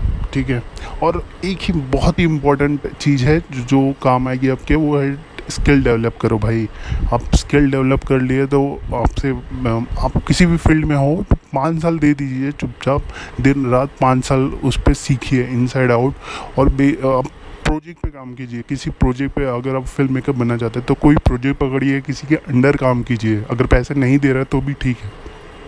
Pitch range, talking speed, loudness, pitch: 125-145 Hz, 195 wpm, -17 LUFS, 135 Hz